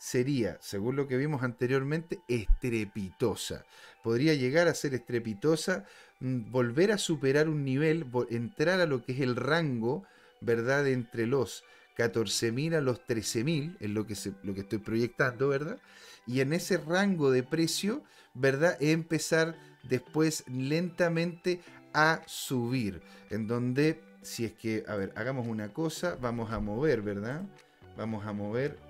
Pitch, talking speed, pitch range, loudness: 130 Hz, 145 wpm, 115-160 Hz, -31 LUFS